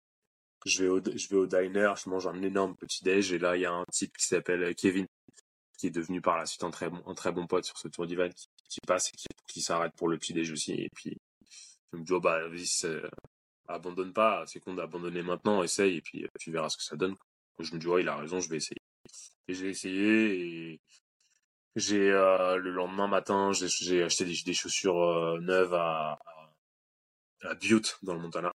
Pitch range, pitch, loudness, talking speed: 85-95 Hz, 90 Hz, -31 LUFS, 225 wpm